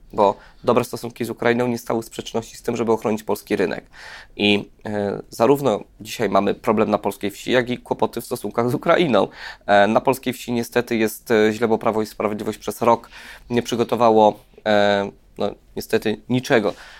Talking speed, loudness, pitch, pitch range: 175 wpm, -21 LUFS, 115 Hz, 105-120 Hz